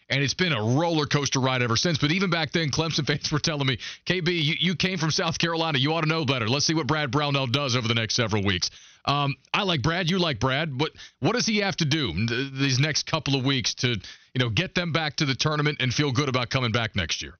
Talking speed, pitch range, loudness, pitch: 270 wpm, 130-165 Hz, -24 LUFS, 145 Hz